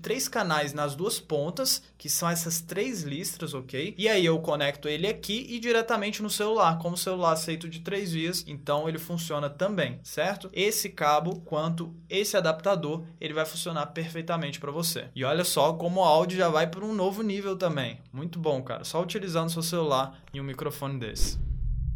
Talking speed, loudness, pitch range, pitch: 185 wpm, -28 LUFS, 150-190 Hz, 165 Hz